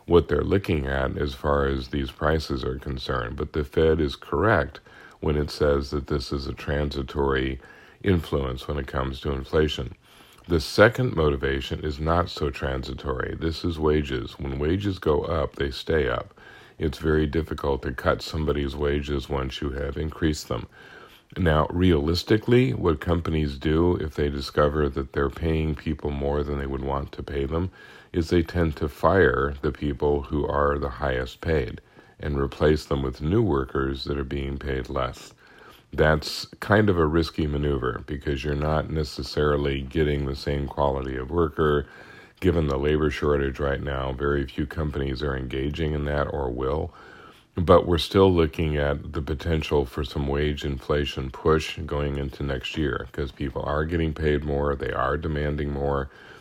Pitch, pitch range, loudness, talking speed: 75 Hz, 70-80 Hz, -25 LUFS, 170 wpm